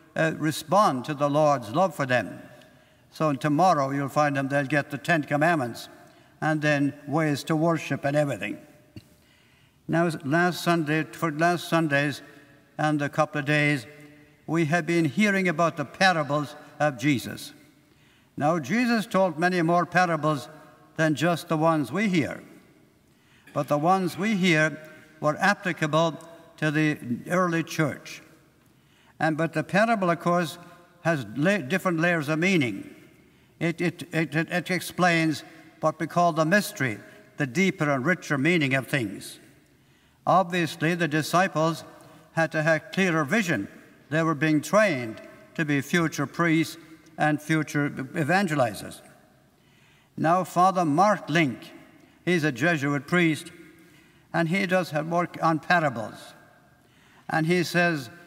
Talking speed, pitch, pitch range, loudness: 135 wpm, 160 Hz, 150-175 Hz, -25 LUFS